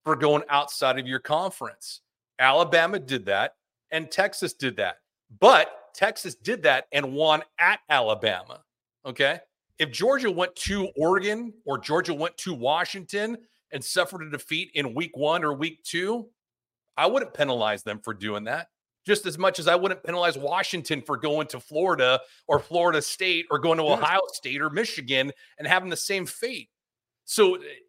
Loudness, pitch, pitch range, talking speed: -25 LUFS, 165 Hz, 145-190 Hz, 165 wpm